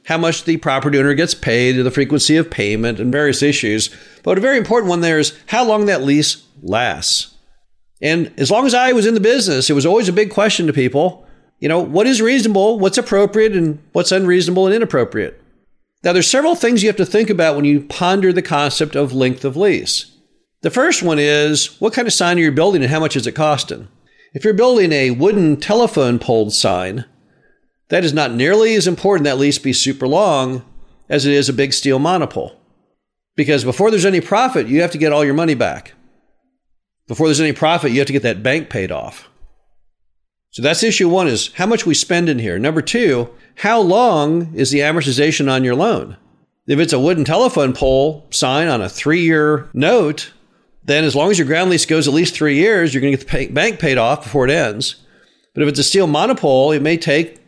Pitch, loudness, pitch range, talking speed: 155 Hz, -15 LUFS, 140-180 Hz, 215 wpm